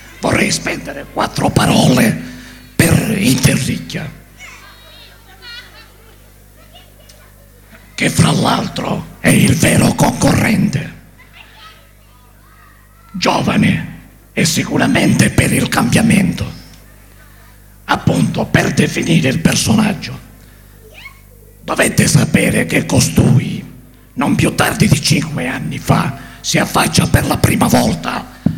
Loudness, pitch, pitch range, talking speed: -14 LUFS, 105 Hz, 100-110 Hz, 85 wpm